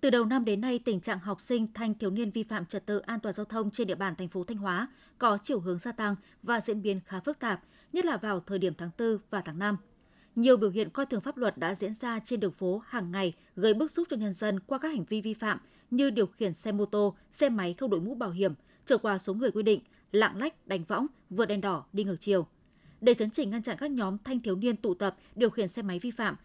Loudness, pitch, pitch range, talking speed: -31 LUFS, 215 Hz, 195-235 Hz, 275 wpm